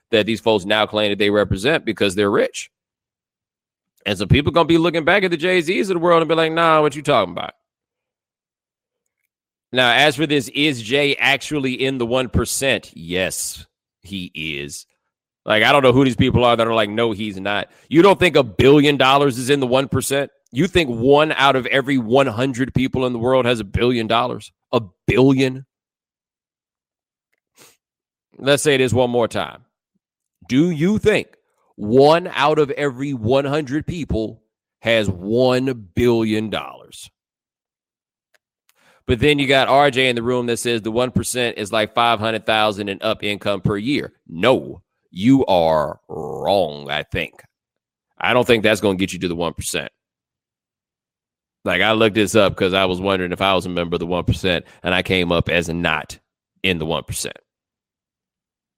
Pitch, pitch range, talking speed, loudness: 120 Hz, 105-140 Hz, 175 wpm, -18 LUFS